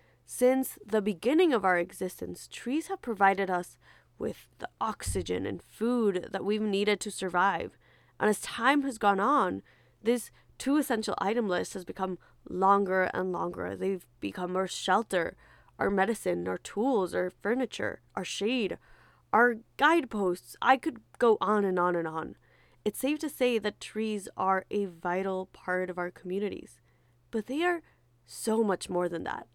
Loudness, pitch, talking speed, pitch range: -30 LUFS, 195 Hz, 160 wpm, 180-235 Hz